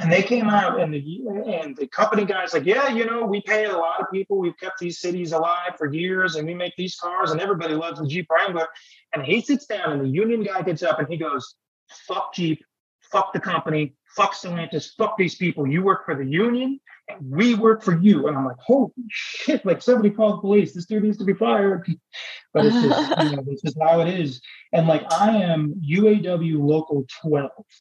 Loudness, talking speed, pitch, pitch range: -22 LUFS, 225 wpm, 180 Hz, 160-210 Hz